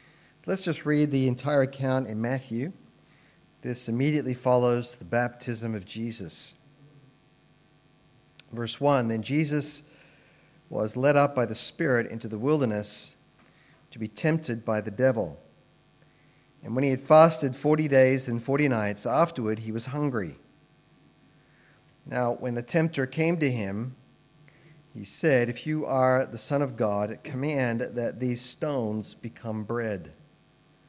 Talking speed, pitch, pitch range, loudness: 135 wpm, 130 Hz, 120-150 Hz, -27 LUFS